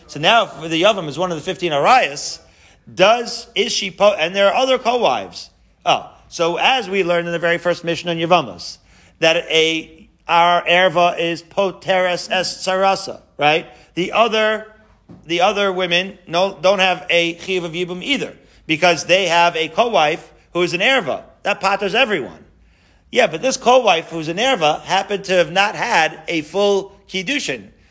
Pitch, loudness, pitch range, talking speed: 180 Hz, -17 LUFS, 170-200 Hz, 170 wpm